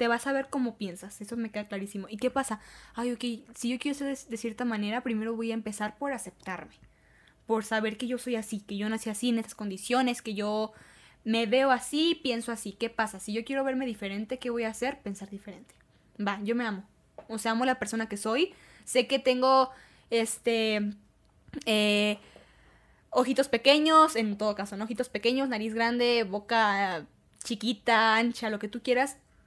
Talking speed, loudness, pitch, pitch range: 195 wpm, -29 LUFS, 230 Hz, 215-250 Hz